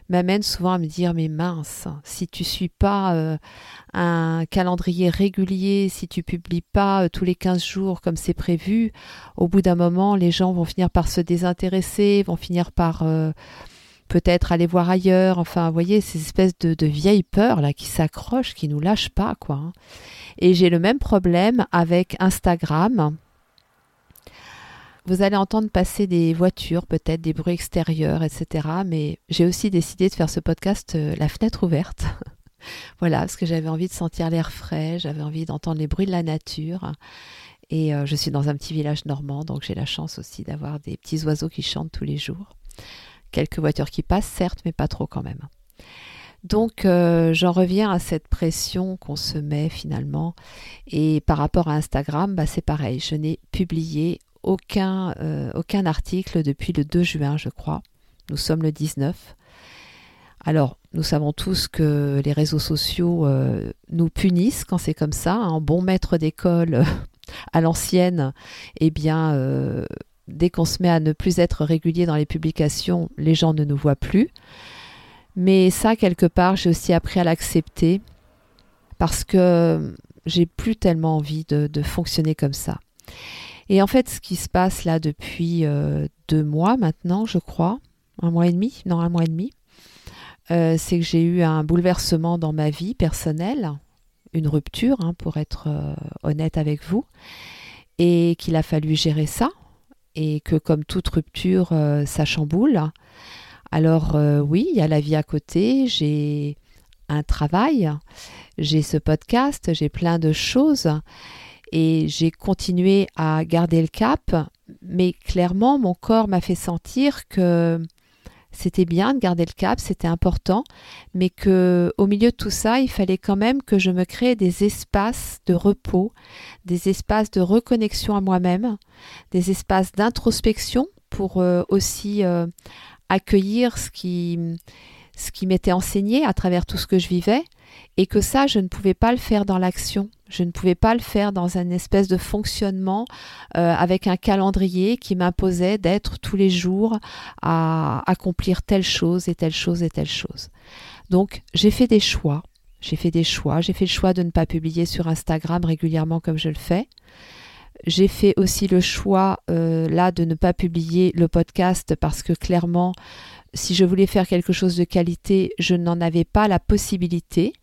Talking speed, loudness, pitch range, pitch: 175 wpm, -21 LUFS, 160-190 Hz, 175 Hz